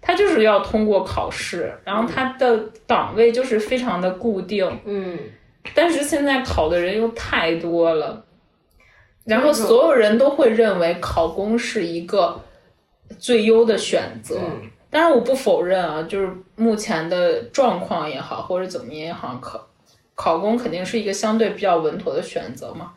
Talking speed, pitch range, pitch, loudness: 245 characters per minute, 185-240 Hz, 220 Hz, -20 LUFS